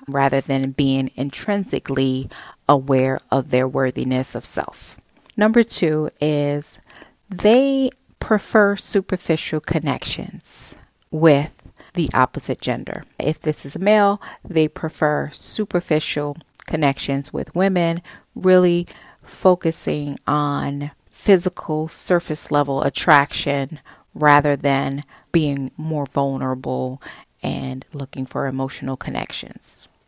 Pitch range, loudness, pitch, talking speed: 135-175 Hz, -19 LUFS, 145 Hz, 100 wpm